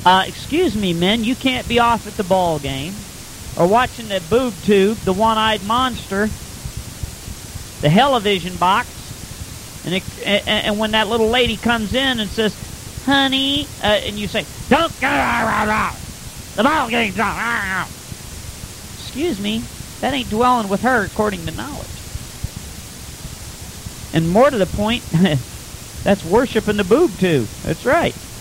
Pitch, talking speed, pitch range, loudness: 210 Hz, 150 wpm, 180-235 Hz, -18 LUFS